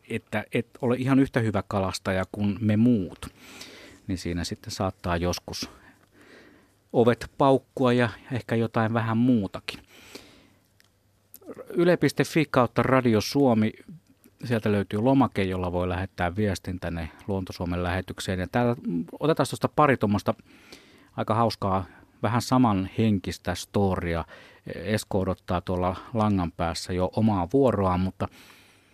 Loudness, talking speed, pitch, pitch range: -26 LUFS, 120 wpm, 105 Hz, 95-120 Hz